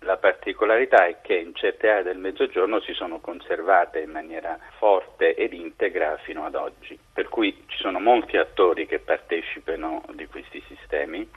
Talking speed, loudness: 165 wpm, -23 LUFS